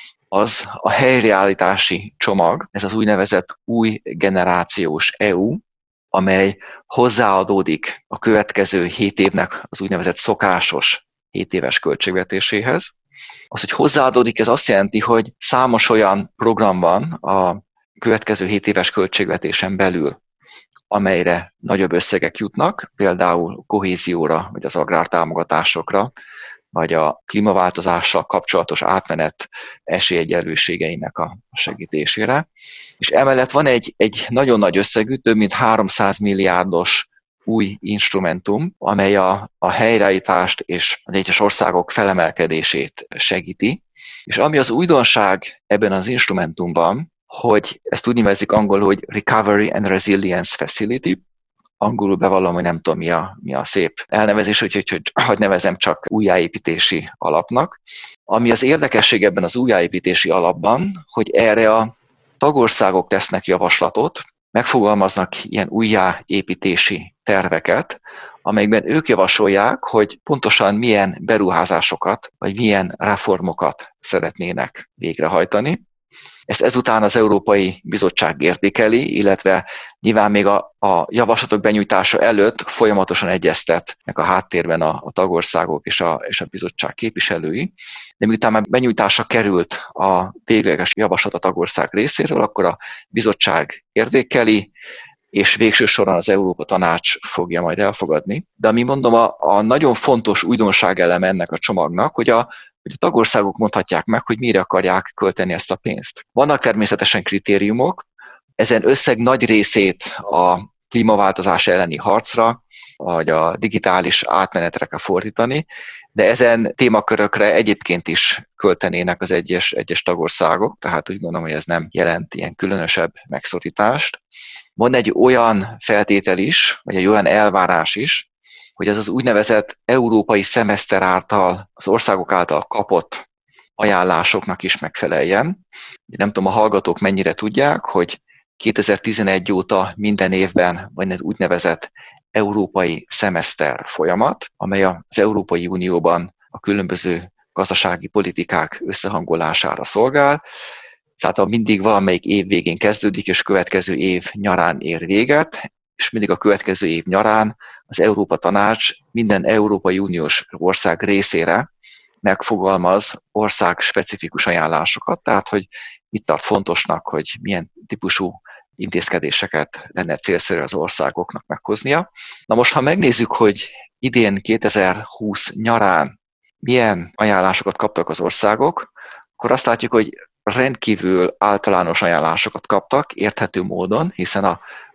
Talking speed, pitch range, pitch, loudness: 125 wpm, 95-110 Hz, 100 Hz, -16 LUFS